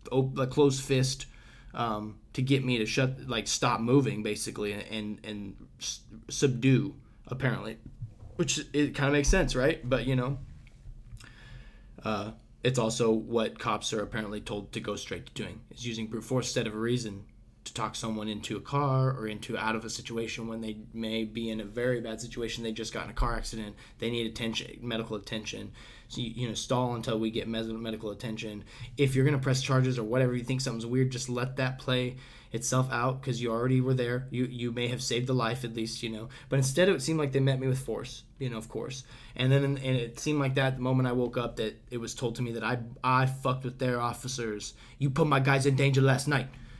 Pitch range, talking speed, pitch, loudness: 110-130 Hz, 220 wpm, 120 Hz, -30 LUFS